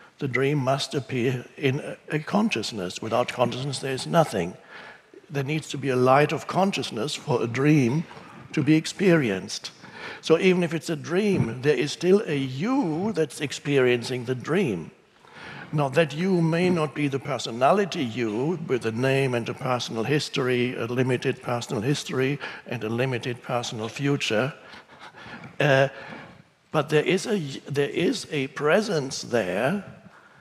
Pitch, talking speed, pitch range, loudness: 140 Hz, 150 wpm, 125-160 Hz, -25 LUFS